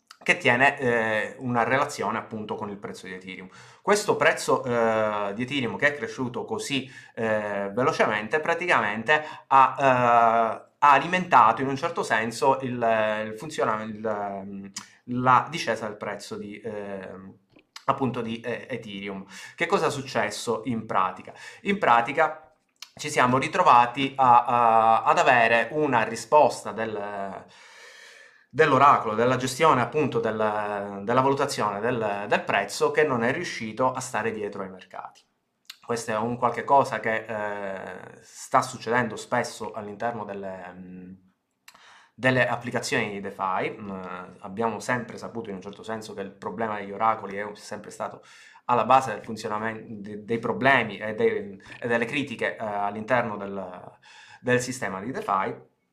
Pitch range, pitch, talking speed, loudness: 105-130 Hz, 115 Hz, 140 wpm, -24 LUFS